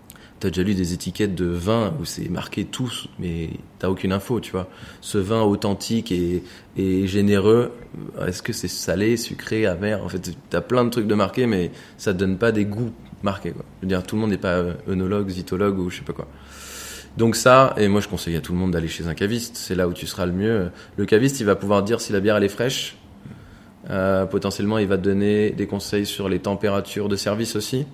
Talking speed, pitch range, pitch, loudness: 230 wpm, 90-110 Hz, 100 Hz, -22 LUFS